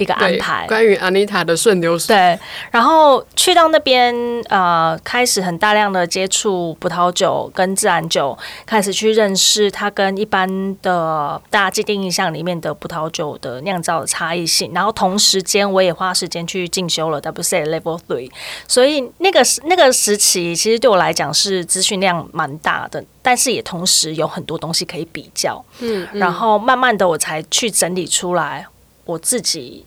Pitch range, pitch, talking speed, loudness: 170-215 Hz, 190 Hz, 285 characters per minute, -15 LUFS